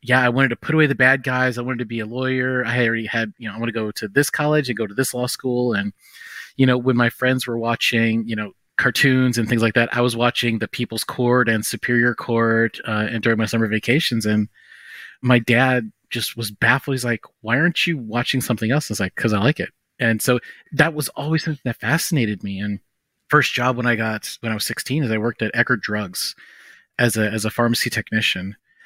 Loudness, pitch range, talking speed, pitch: -20 LUFS, 110-130 Hz, 240 wpm, 120 Hz